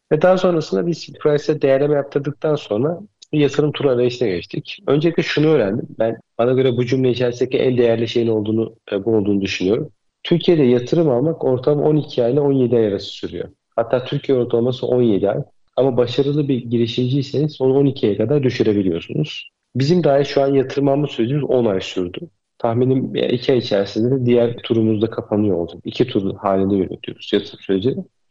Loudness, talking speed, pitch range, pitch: -18 LUFS, 165 wpm, 115-145 Hz, 125 Hz